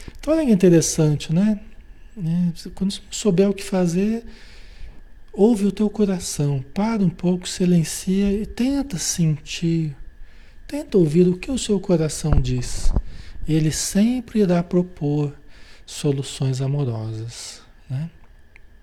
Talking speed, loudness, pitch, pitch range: 110 wpm, -21 LUFS, 175 Hz, 140-200 Hz